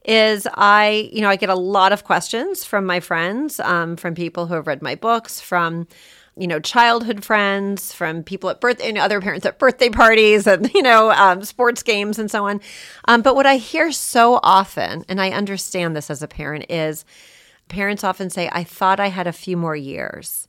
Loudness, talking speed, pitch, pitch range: -17 LUFS, 215 wpm, 200 Hz, 175-225 Hz